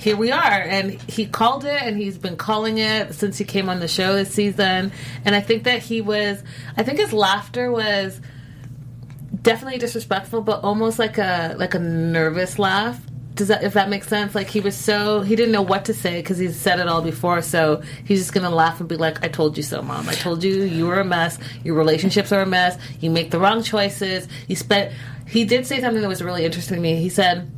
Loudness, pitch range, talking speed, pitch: -20 LUFS, 165-210 Hz, 235 wpm, 195 Hz